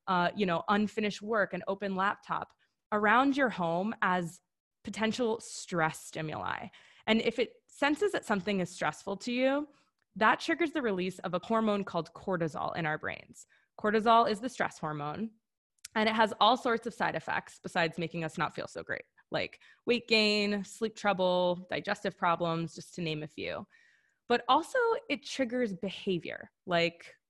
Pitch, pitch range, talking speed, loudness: 205 Hz, 180-230 Hz, 165 wpm, -31 LUFS